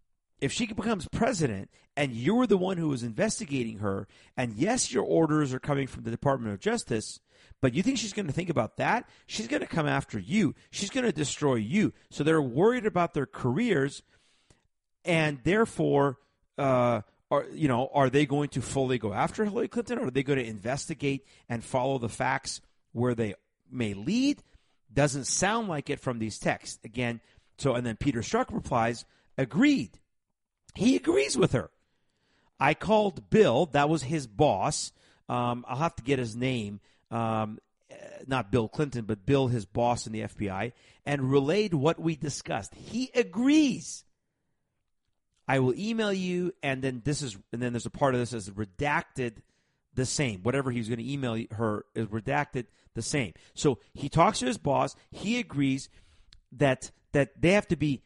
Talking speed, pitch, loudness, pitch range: 175 wpm, 135 Hz, -29 LUFS, 115-165 Hz